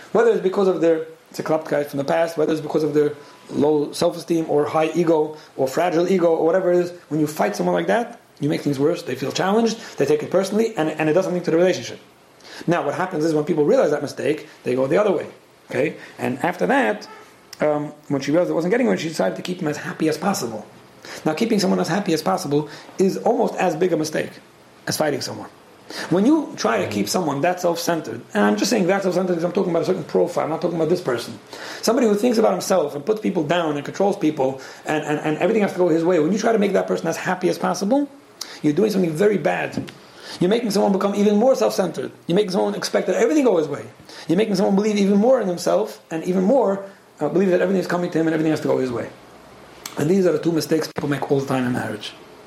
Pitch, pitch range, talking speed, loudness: 175 Hz, 155-195 Hz, 260 wpm, -20 LUFS